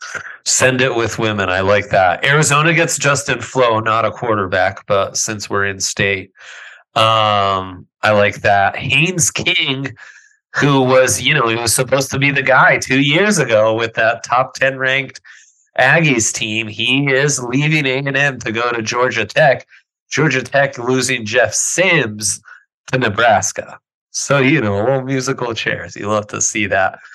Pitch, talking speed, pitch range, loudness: 130 Hz, 165 wpm, 110-140 Hz, -14 LUFS